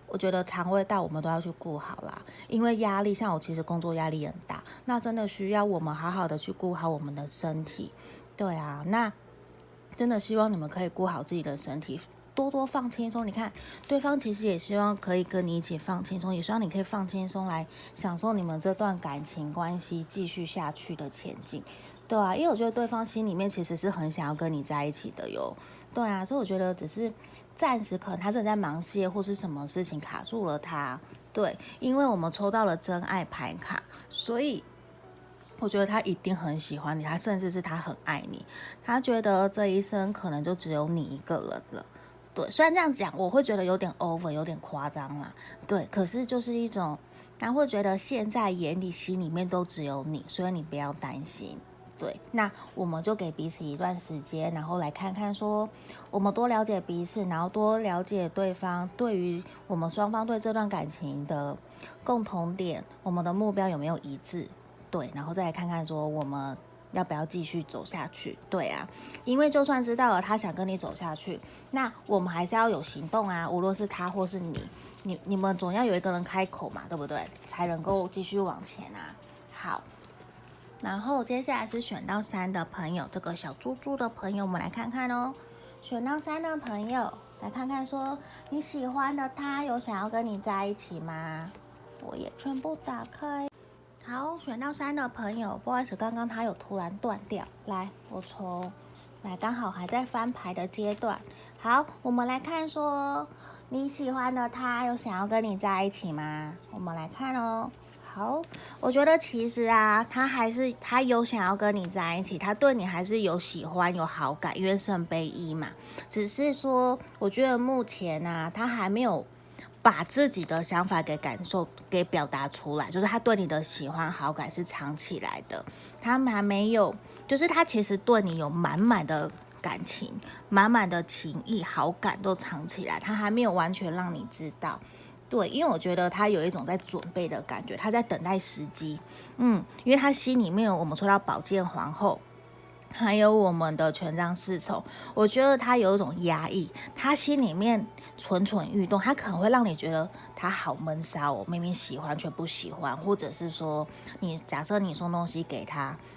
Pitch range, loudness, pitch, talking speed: 165-225 Hz, -30 LUFS, 190 Hz, 280 characters per minute